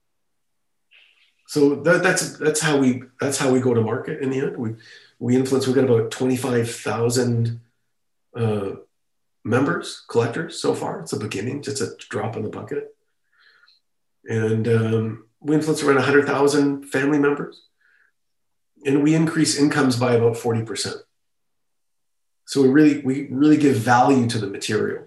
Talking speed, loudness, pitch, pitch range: 160 wpm, -21 LUFS, 130 Hz, 115-145 Hz